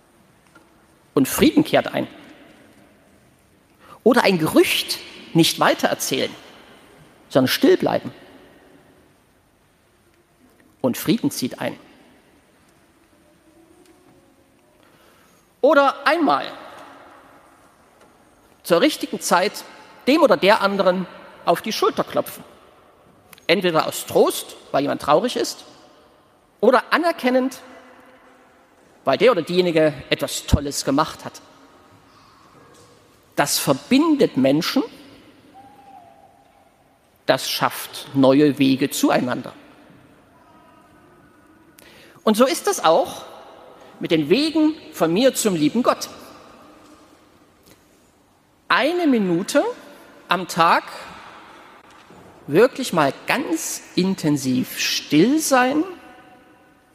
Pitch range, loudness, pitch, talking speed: 190-315 Hz, -19 LUFS, 270 Hz, 80 wpm